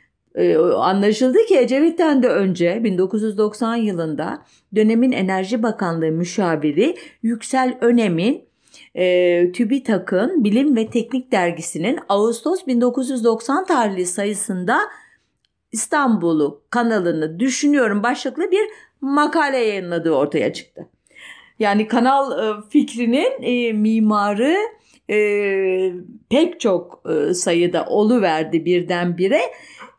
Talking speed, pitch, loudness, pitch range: 80 wpm, 225 Hz, -18 LUFS, 185-260 Hz